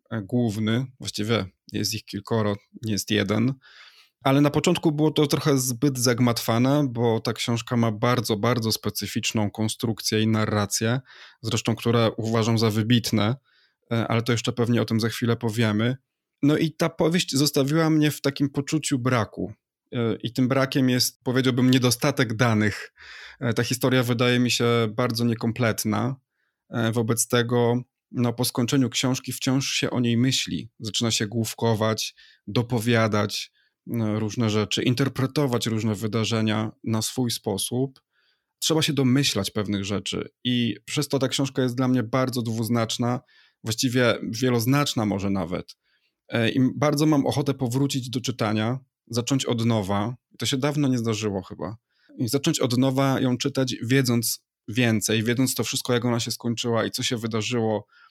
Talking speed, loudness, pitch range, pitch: 145 wpm, -24 LUFS, 110-130 Hz, 120 Hz